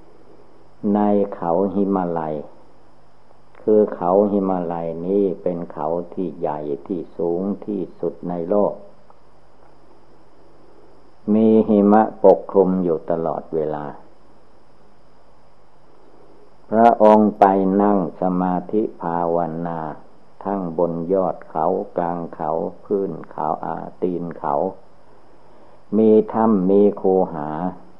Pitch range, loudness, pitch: 85-100 Hz, -20 LUFS, 95 Hz